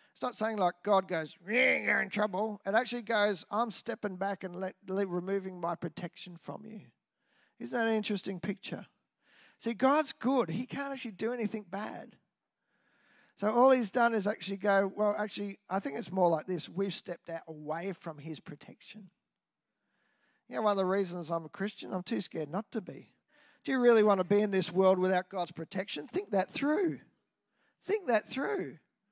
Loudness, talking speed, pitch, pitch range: -32 LUFS, 190 wpm, 205 Hz, 185-235 Hz